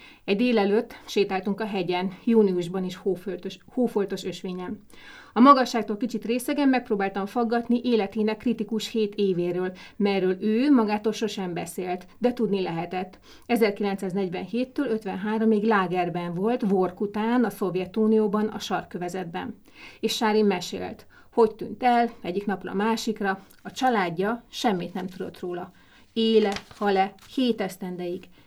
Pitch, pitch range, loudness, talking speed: 205 Hz, 185-225 Hz, -25 LUFS, 120 wpm